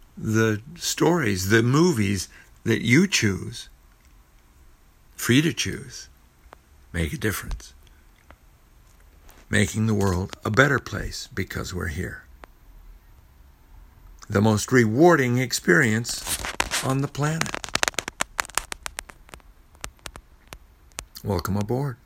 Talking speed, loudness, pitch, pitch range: 85 wpm, -23 LUFS, 105 Hz, 80-120 Hz